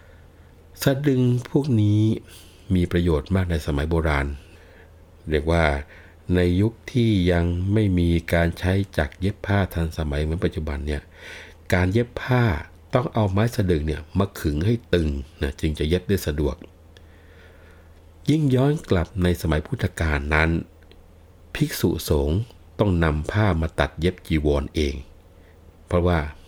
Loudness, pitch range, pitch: -23 LUFS, 80-95 Hz, 85 Hz